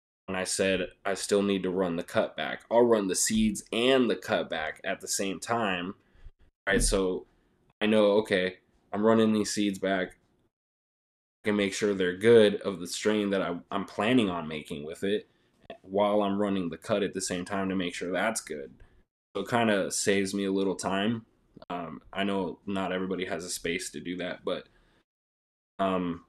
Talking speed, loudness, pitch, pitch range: 200 wpm, -28 LUFS, 95 Hz, 90-105 Hz